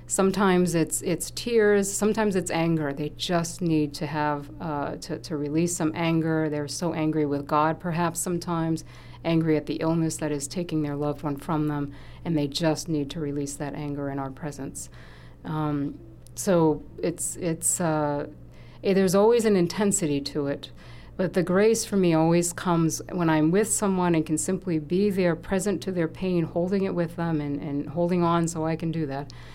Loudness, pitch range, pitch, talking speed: -26 LUFS, 145-175 Hz, 160 Hz, 190 wpm